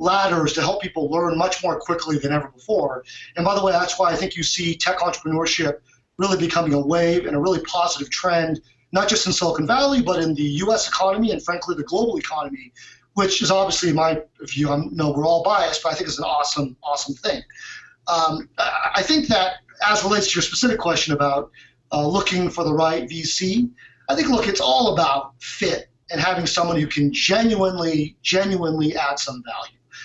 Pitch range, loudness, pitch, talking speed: 150-190 Hz, -20 LUFS, 170 Hz, 200 wpm